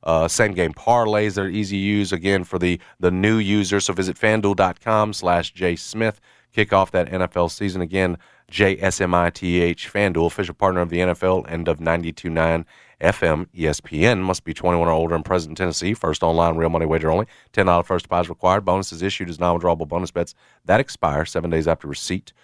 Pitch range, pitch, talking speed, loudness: 85-100 Hz, 90 Hz, 205 wpm, -21 LUFS